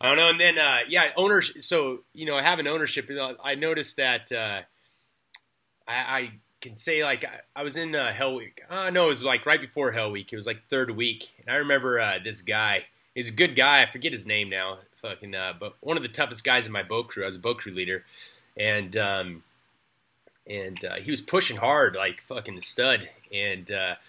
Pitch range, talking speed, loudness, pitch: 100-150 Hz, 230 wpm, -25 LUFS, 125 Hz